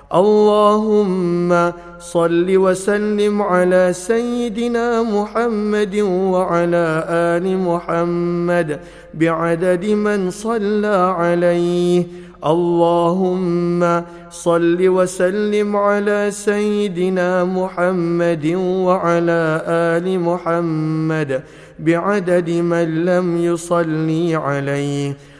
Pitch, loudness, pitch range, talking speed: 175 Hz, -17 LUFS, 170-200 Hz, 65 wpm